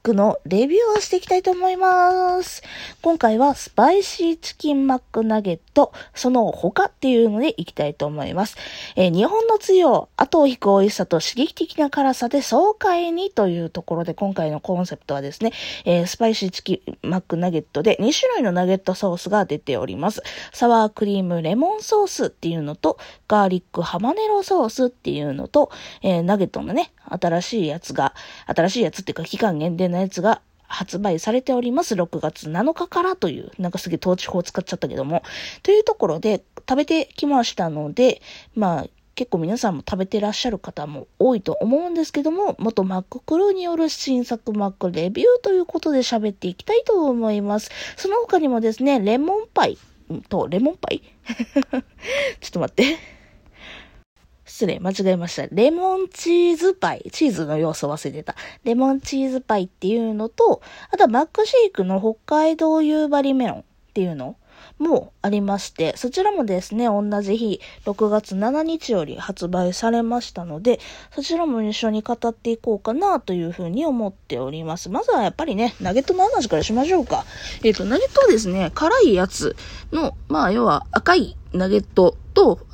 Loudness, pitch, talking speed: -20 LUFS, 230 Hz, 375 characters per minute